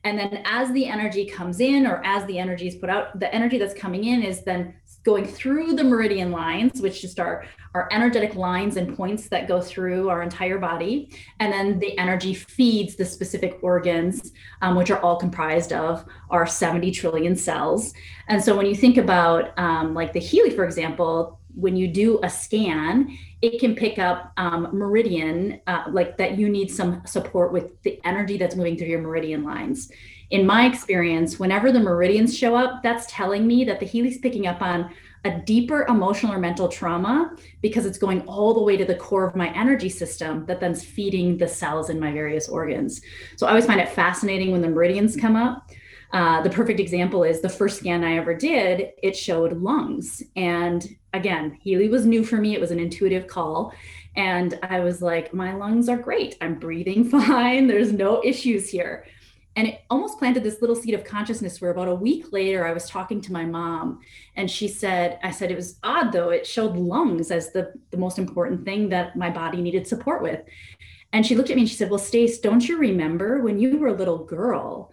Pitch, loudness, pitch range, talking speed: 190 Hz, -22 LUFS, 175-225 Hz, 205 wpm